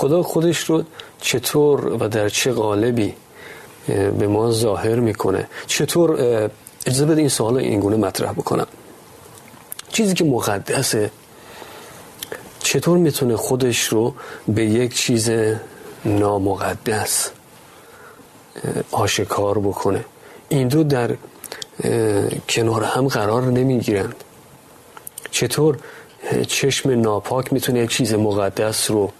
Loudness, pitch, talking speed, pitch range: -19 LUFS, 115 Hz, 100 wpm, 105-135 Hz